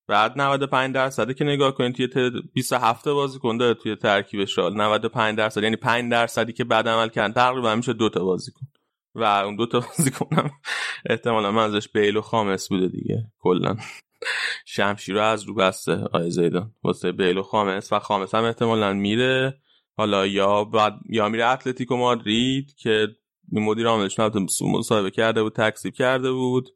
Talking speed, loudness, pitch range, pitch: 165 wpm, -22 LUFS, 105-125 Hz, 110 Hz